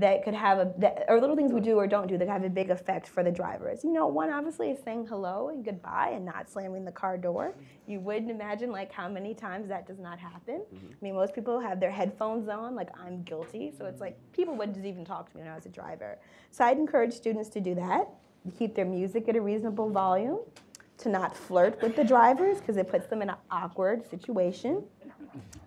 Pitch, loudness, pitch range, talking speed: 205 Hz, -30 LUFS, 185-235 Hz, 240 wpm